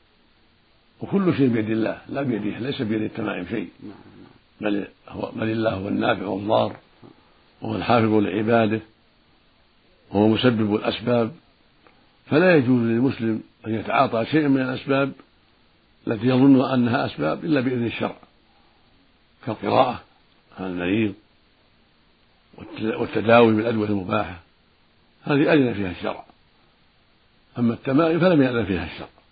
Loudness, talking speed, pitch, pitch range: -22 LUFS, 110 wpm, 115 Hz, 105-125 Hz